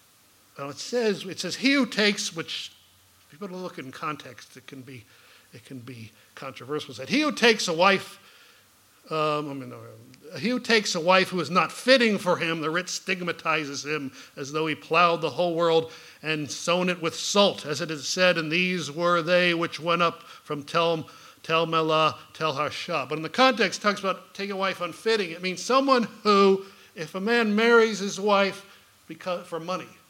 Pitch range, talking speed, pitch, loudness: 150-195 Hz, 195 wpm, 170 Hz, -24 LUFS